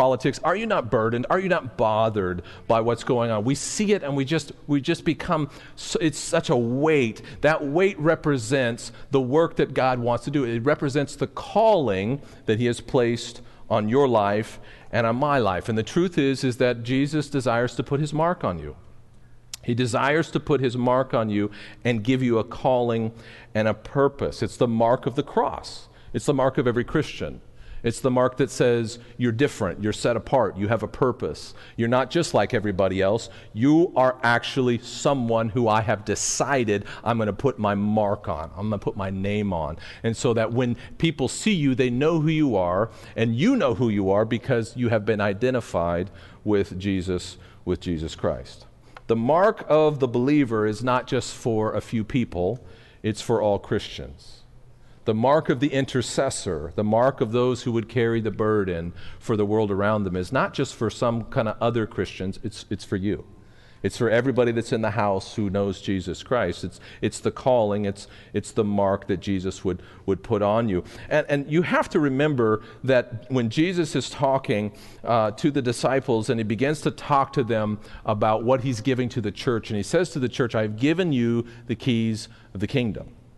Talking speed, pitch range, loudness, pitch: 200 wpm, 105-135 Hz, -24 LUFS, 120 Hz